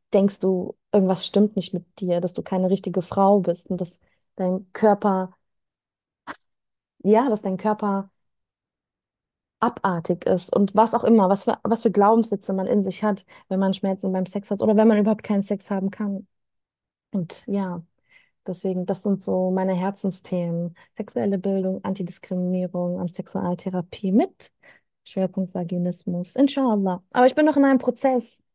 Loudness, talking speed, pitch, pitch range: -23 LUFS, 155 wpm, 195 Hz, 185-215 Hz